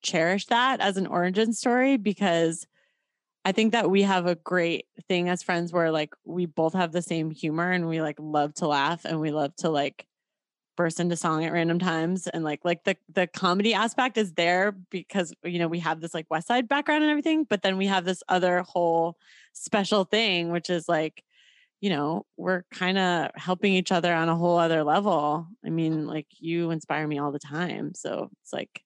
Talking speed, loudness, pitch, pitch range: 210 wpm, -26 LUFS, 175 Hz, 165-195 Hz